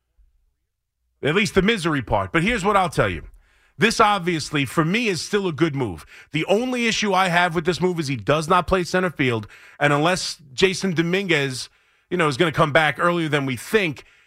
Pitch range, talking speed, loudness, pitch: 135-190 Hz, 210 wpm, -21 LUFS, 170 Hz